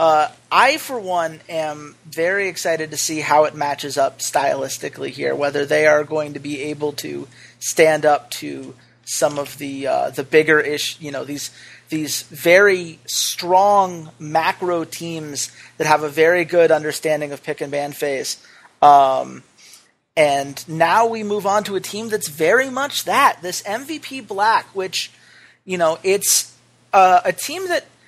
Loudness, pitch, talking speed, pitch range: -18 LUFS, 160 Hz, 160 wpm, 145-185 Hz